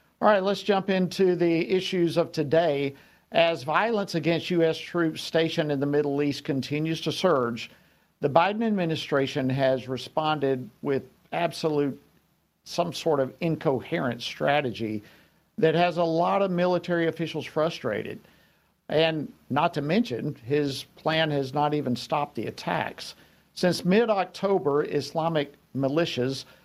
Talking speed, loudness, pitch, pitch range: 135 wpm, -26 LUFS, 160 Hz, 145-175 Hz